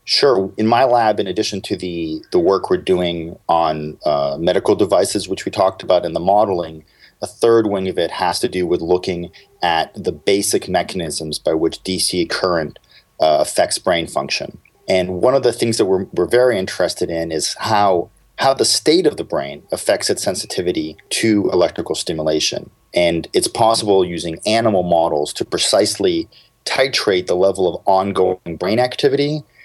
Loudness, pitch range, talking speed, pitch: -17 LUFS, 80-100 Hz, 170 wpm, 90 Hz